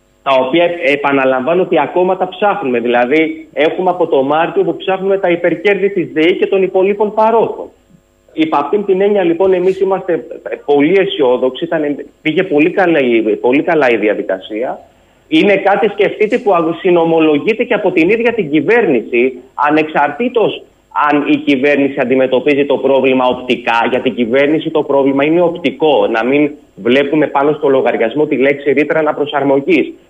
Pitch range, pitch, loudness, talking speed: 140-190 Hz, 155 Hz, -12 LUFS, 150 wpm